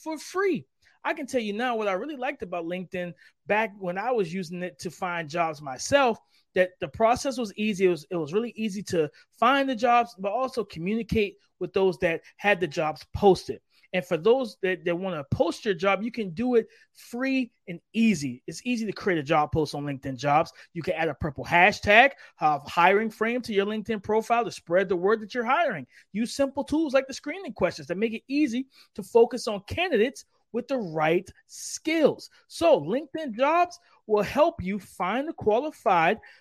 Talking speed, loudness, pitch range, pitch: 205 wpm, -26 LUFS, 180-250 Hz, 215 Hz